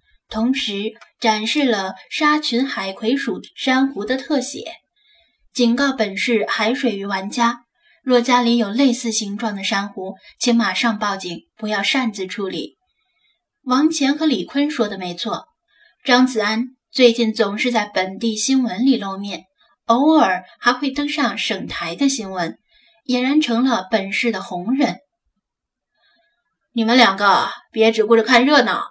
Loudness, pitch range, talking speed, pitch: -18 LUFS, 215-270 Hz, 210 characters per minute, 235 Hz